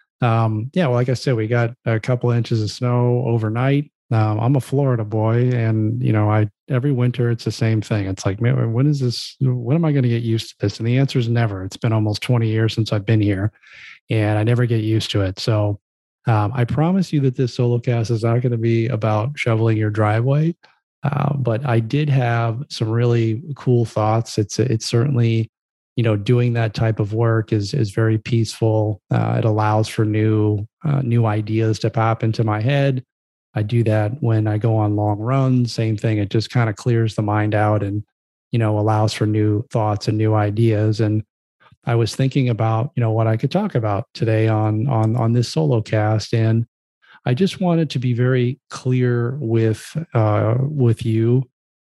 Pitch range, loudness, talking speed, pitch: 110-125 Hz, -19 LUFS, 210 wpm, 115 Hz